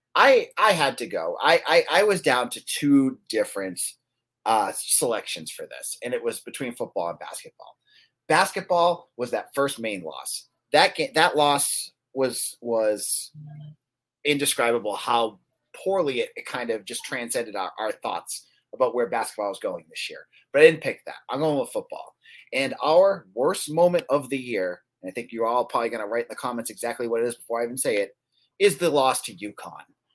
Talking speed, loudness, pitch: 195 wpm, -24 LUFS, 150 Hz